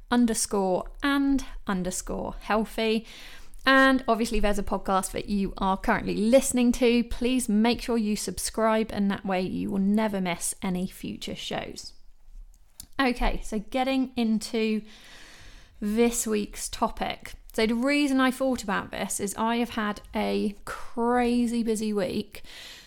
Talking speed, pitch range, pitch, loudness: 135 wpm, 205-240 Hz, 225 Hz, -26 LUFS